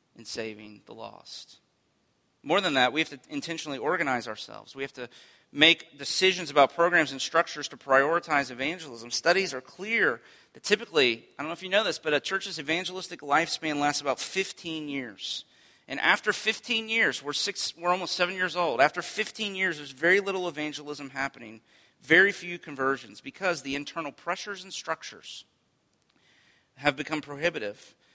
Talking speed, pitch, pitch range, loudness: 165 wpm, 155 Hz, 135-180 Hz, -27 LUFS